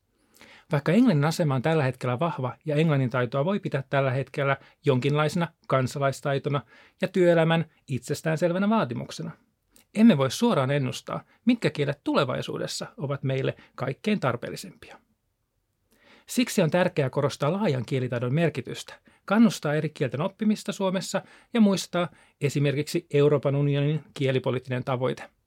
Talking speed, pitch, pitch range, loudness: 120 wpm, 145 Hz, 135-180 Hz, -26 LUFS